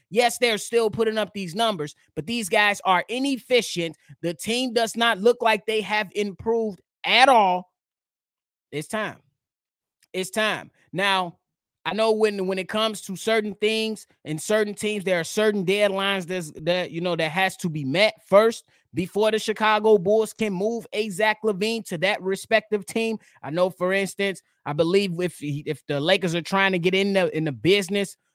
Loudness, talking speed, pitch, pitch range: -23 LUFS, 180 wpm, 200 Hz, 180-220 Hz